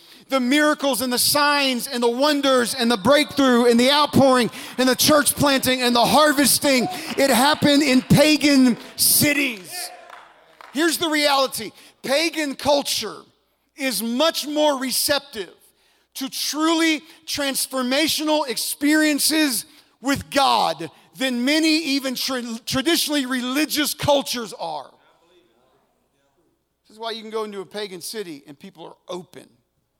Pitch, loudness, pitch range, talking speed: 270 Hz, -19 LUFS, 240-295 Hz, 125 wpm